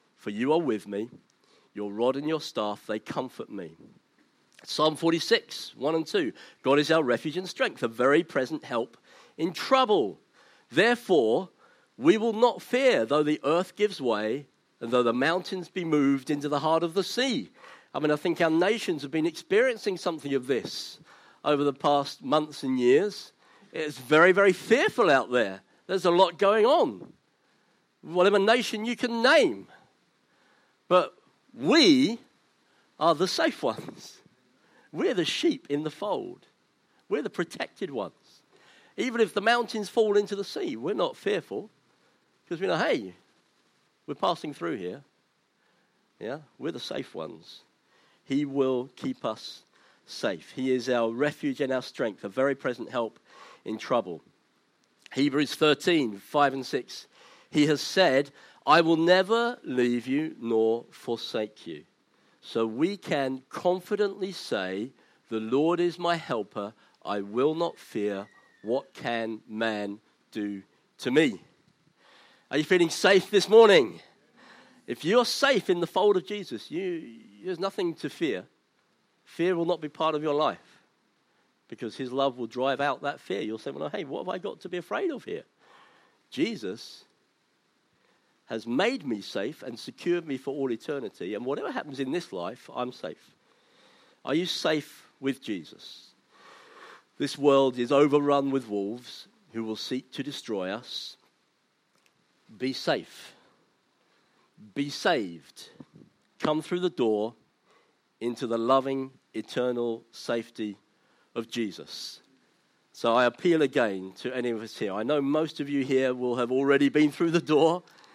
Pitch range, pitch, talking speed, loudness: 130-185 Hz, 150 Hz, 155 wpm, -27 LUFS